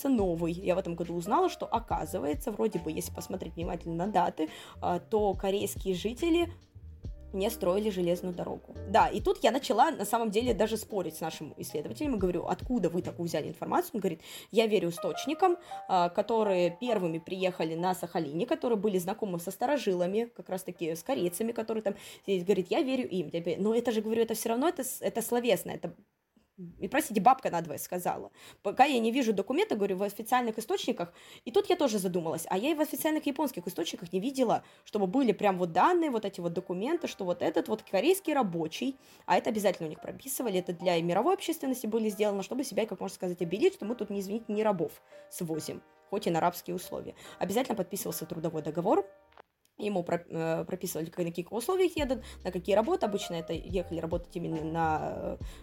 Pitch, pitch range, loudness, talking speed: 195 Hz, 175-235 Hz, -31 LUFS, 190 wpm